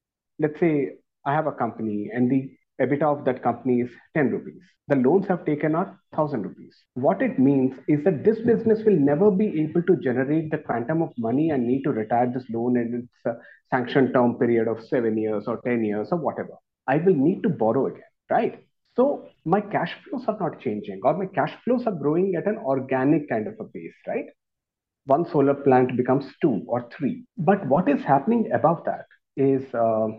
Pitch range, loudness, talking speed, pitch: 125-175 Hz, -23 LUFS, 200 wpm, 140 Hz